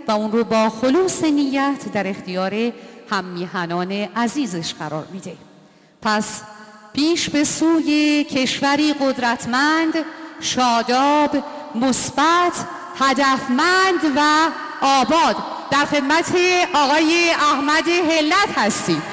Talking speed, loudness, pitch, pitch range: 95 wpm, -18 LUFS, 280 Hz, 230-315 Hz